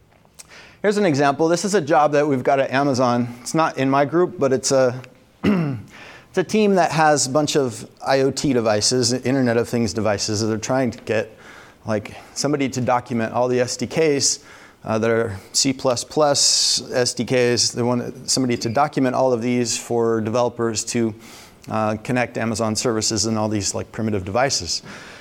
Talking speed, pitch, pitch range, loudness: 170 wpm, 125 Hz, 115-140 Hz, -20 LUFS